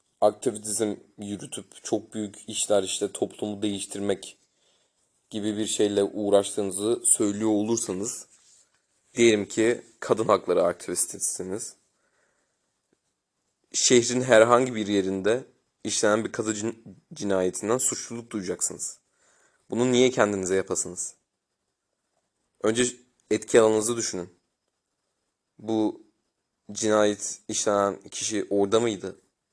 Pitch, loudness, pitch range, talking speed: 105 Hz, -25 LUFS, 100-115 Hz, 90 wpm